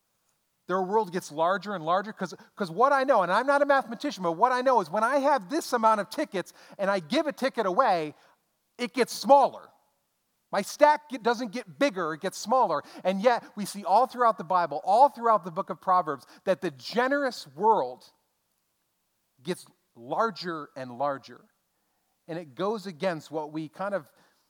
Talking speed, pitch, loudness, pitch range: 180 wpm, 200 Hz, -27 LUFS, 175-250 Hz